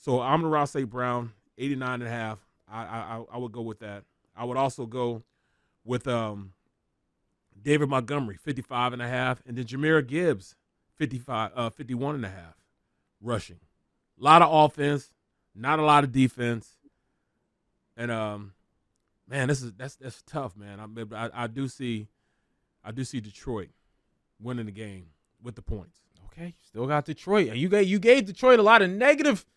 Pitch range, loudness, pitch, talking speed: 110-145 Hz, -26 LUFS, 125 Hz, 175 wpm